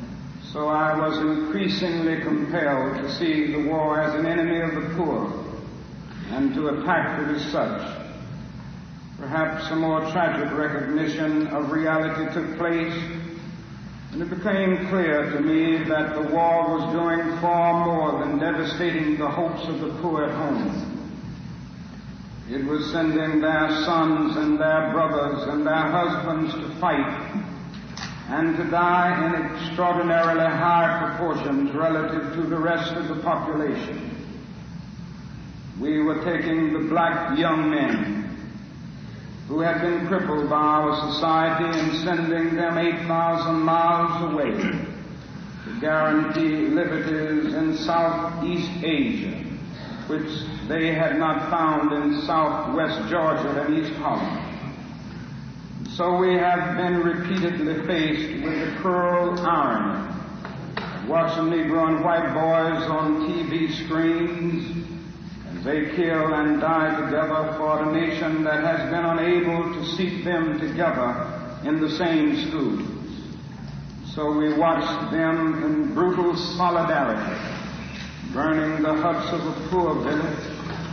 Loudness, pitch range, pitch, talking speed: -23 LUFS, 155-170 Hz, 160 Hz, 125 wpm